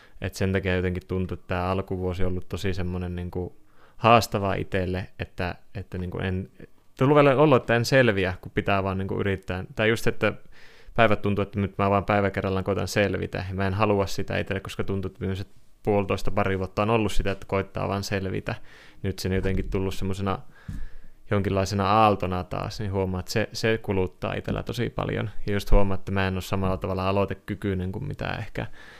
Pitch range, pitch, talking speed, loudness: 95-105 Hz, 100 Hz, 195 wpm, -26 LUFS